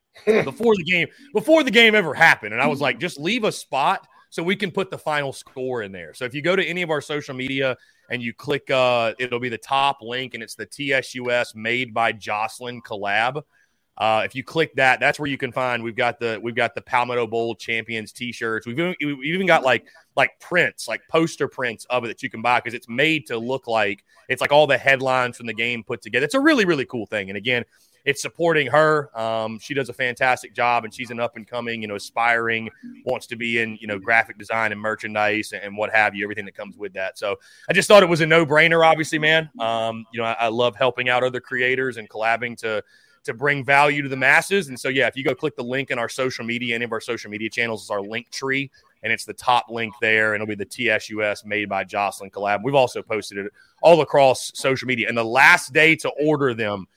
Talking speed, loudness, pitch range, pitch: 240 wpm, -21 LUFS, 115-145 Hz, 125 Hz